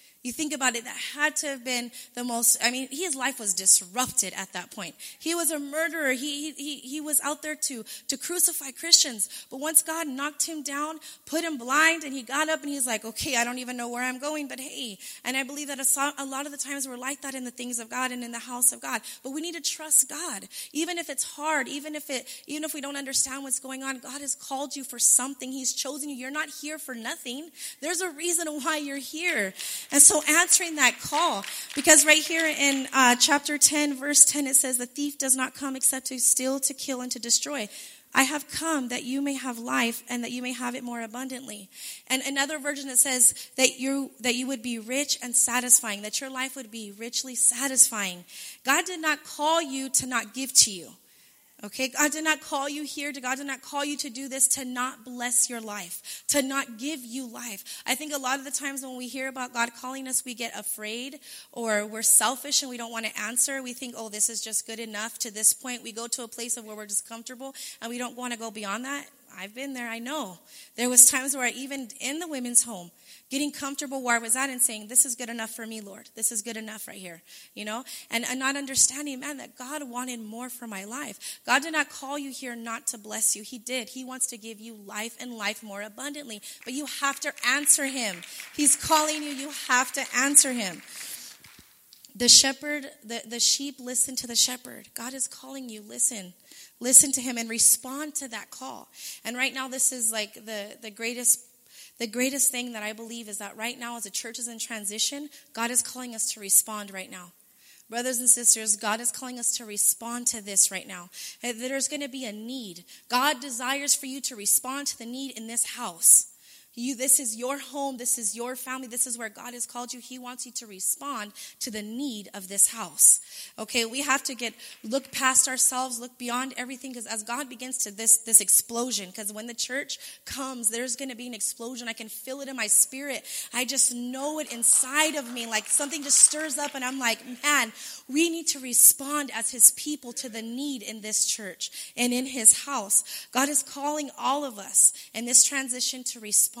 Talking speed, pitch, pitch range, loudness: 230 wpm, 255 Hz, 235-280 Hz, -24 LUFS